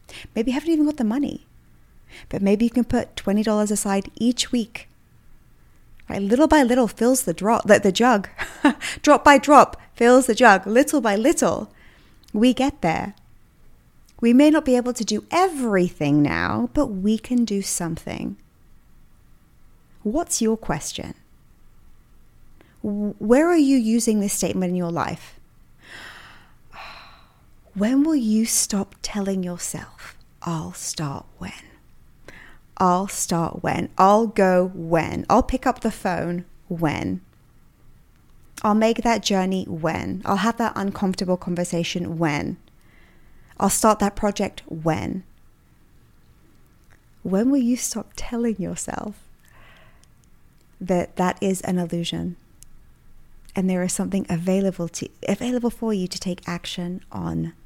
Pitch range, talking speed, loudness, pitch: 180-245 Hz, 130 wpm, -21 LUFS, 205 Hz